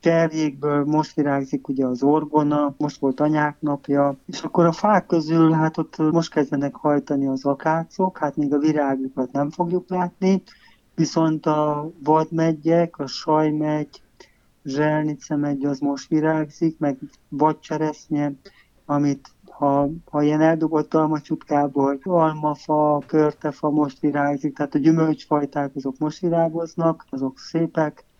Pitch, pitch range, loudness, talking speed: 150 Hz, 145-160 Hz, -22 LUFS, 125 wpm